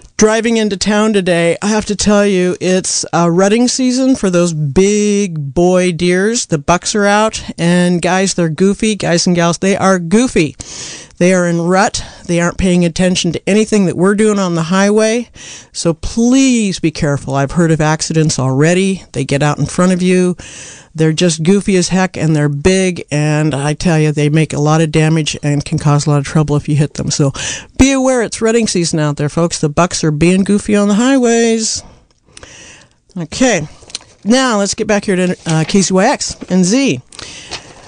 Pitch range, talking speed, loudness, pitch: 160-205 Hz, 195 wpm, -12 LUFS, 180 Hz